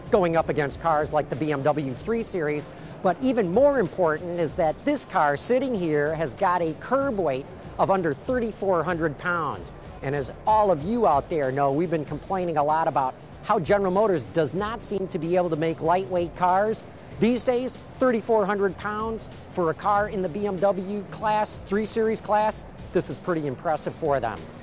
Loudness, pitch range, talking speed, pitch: -25 LUFS, 155-210 Hz, 185 wpm, 180 Hz